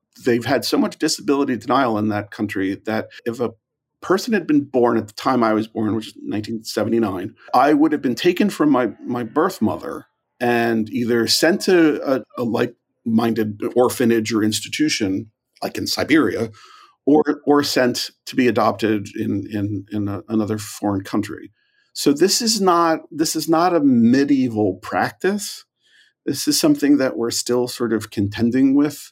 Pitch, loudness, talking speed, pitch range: 125 Hz, -19 LUFS, 165 wpm, 110-155 Hz